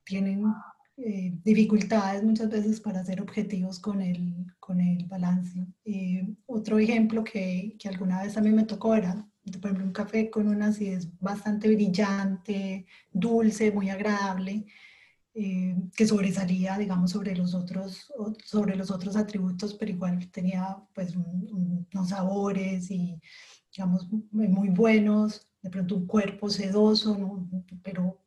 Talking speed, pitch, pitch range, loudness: 145 wpm, 195 Hz, 185-210 Hz, -28 LUFS